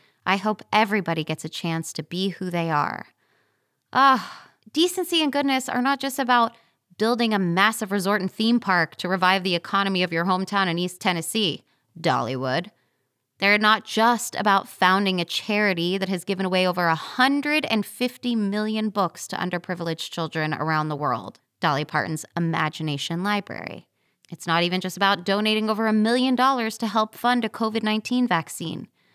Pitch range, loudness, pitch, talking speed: 170-220 Hz, -23 LUFS, 195 Hz, 165 wpm